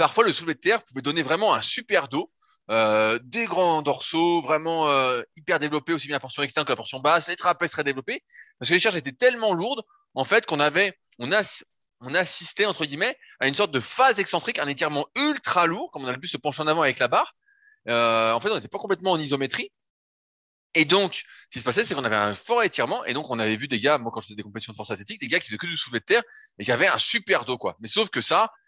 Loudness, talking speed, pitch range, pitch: -23 LUFS, 270 wpm, 135-195 Hz, 155 Hz